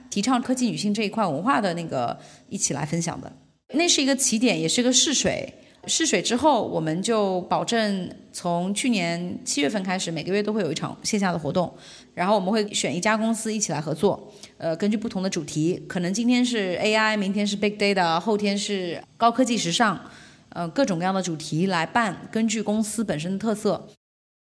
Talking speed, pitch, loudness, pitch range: 315 characters per minute, 205 Hz, -24 LUFS, 175-225 Hz